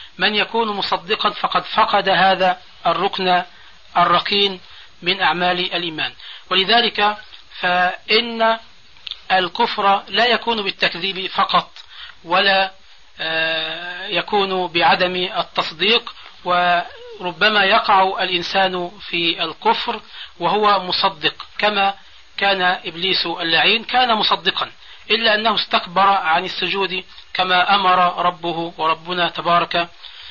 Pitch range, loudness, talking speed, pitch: 175-205 Hz, -17 LUFS, 90 wpm, 185 Hz